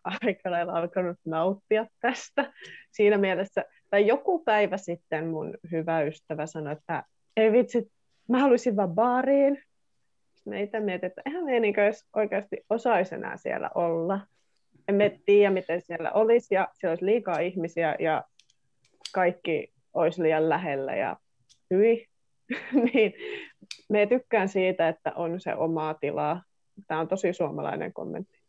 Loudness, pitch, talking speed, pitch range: -27 LUFS, 195 Hz, 130 wpm, 165-225 Hz